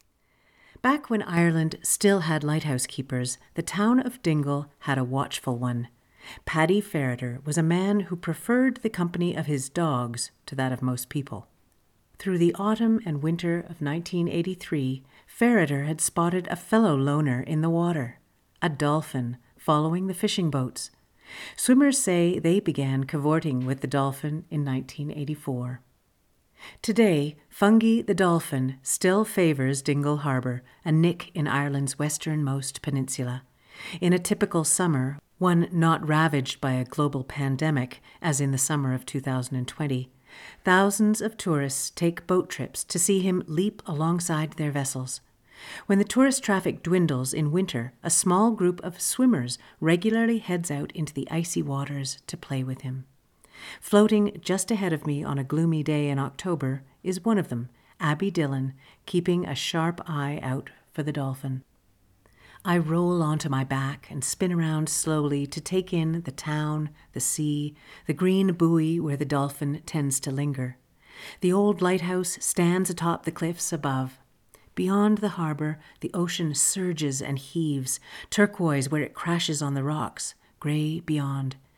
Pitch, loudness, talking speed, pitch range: 155 Hz, -26 LUFS, 150 wpm, 135-180 Hz